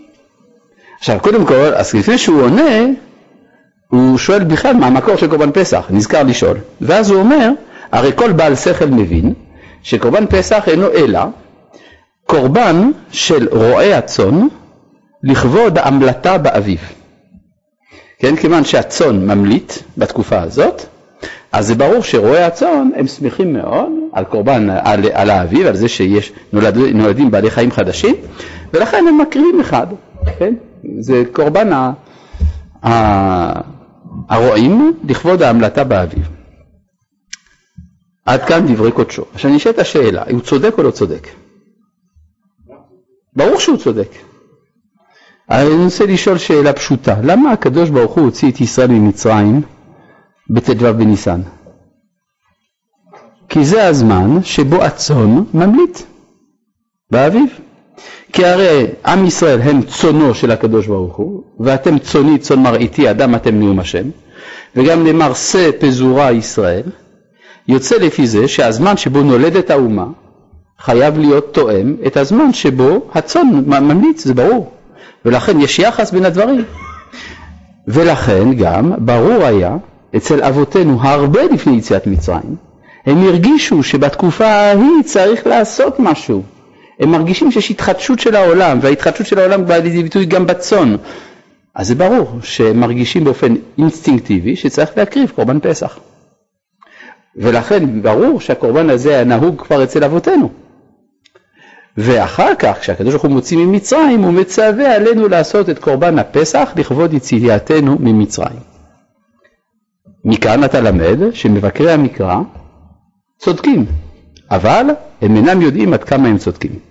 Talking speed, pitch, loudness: 125 wpm, 150 Hz, -11 LUFS